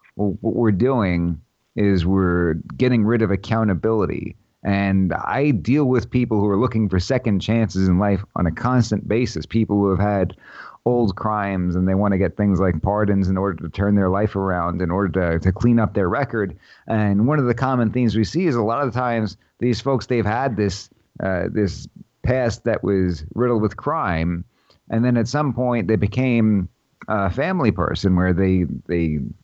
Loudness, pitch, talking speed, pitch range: -20 LUFS, 105 Hz, 195 wpm, 95-115 Hz